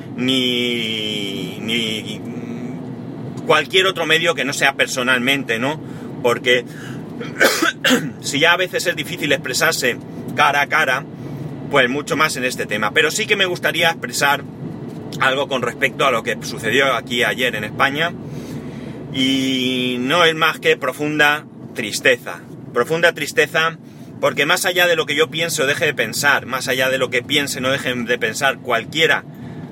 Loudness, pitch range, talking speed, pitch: -17 LUFS, 125-160 Hz, 150 wpm, 135 Hz